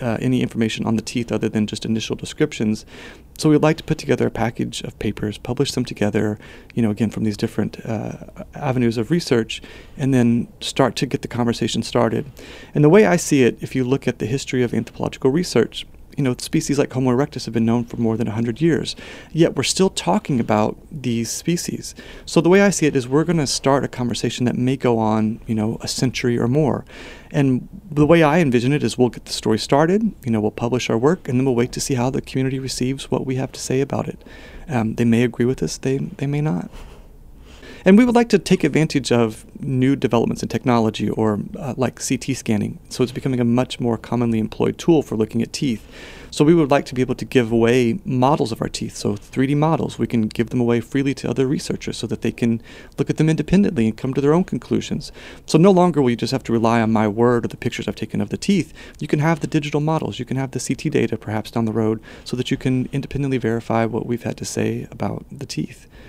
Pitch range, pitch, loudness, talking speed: 115-145 Hz, 125 Hz, -20 LUFS, 240 wpm